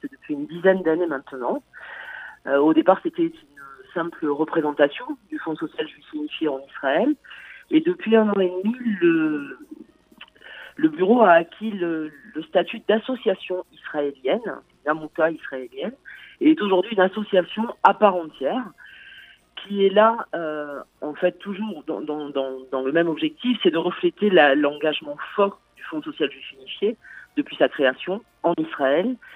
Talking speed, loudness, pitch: 150 wpm, -22 LUFS, 190 Hz